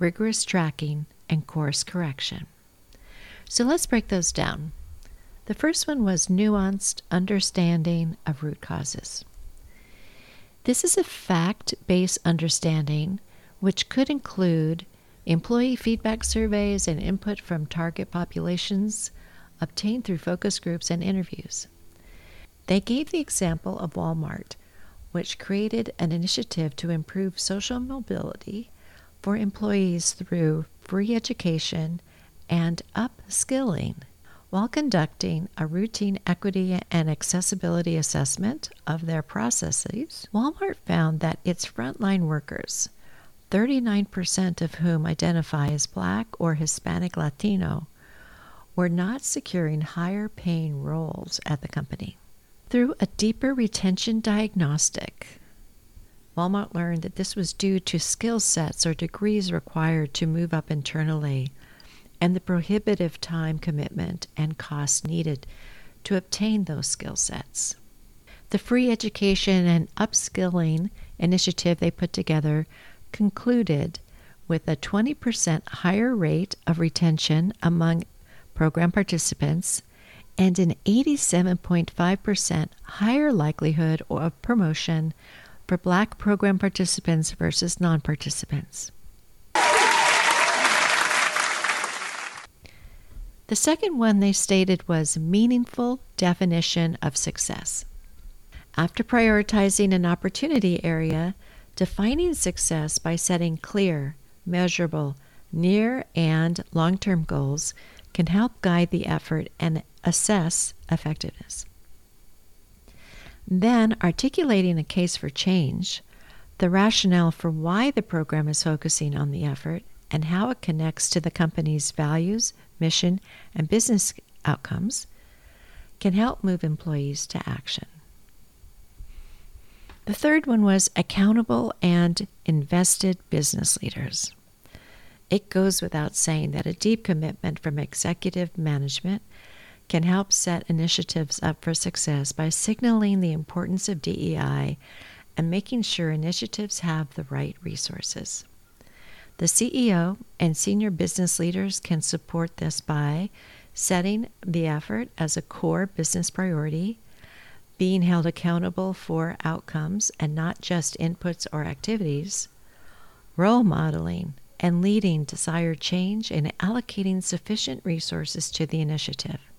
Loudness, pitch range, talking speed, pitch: -25 LUFS, 160-200 Hz, 110 wpm, 175 Hz